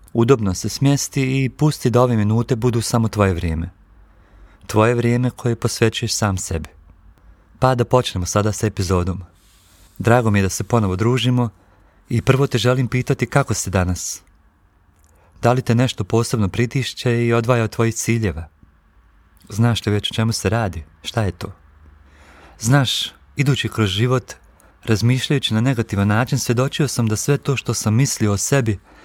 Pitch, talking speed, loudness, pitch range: 110 Hz, 160 wpm, -19 LUFS, 95-125 Hz